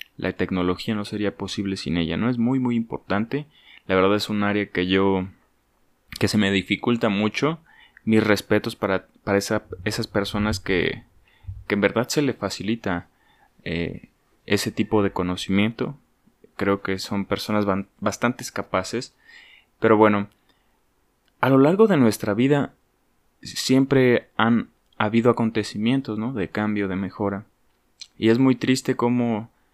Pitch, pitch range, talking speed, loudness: 105 Hz, 100-120 Hz, 145 wpm, -23 LUFS